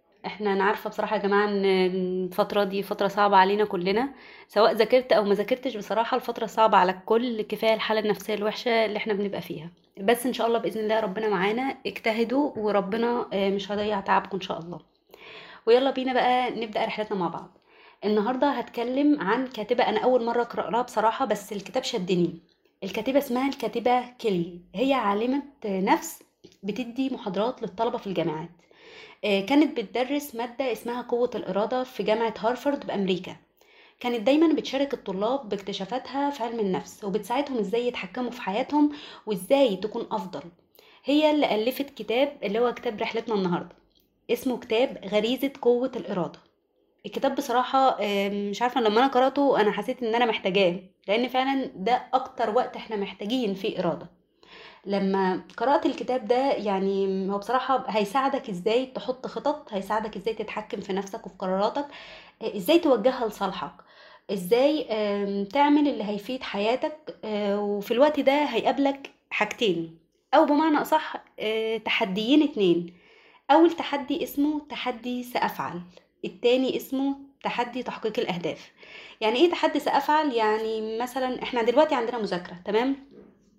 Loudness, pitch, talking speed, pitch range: -26 LUFS, 230 Hz, 140 wpm, 205-260 Hz